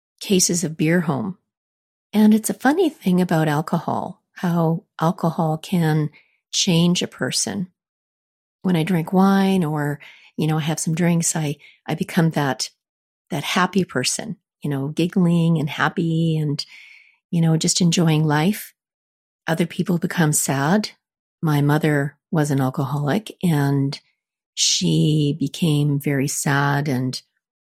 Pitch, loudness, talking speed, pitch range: 165 Hz, -20 LUFS, 130 wpm, 150-180 Hz